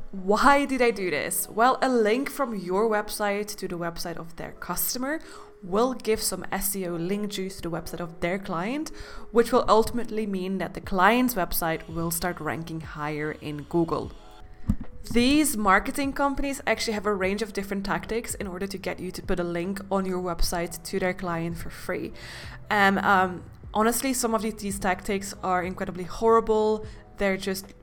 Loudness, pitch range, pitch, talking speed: -26 LUFS, 175-220 Hz, 195 Hz, 180 wpm